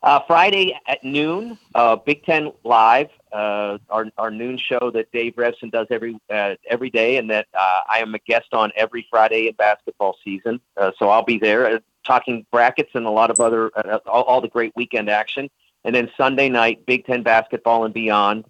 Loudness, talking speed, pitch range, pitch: -19 LUFS, 200 wpm, 110-125 Hz, 115 Hz